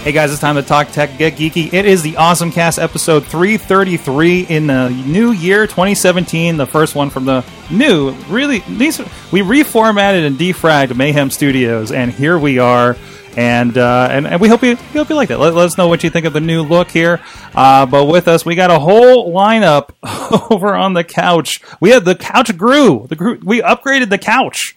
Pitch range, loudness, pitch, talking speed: 145-200 Hz, -11 LUFS, 170 Hz, 220 wpm